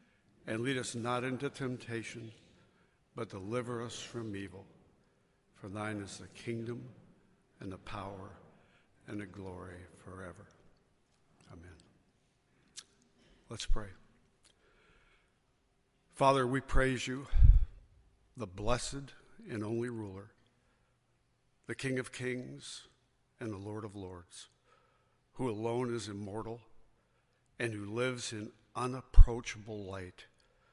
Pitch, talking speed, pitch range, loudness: 115 Hz, 105 wpm, 100-125 Hz, -37 LUFS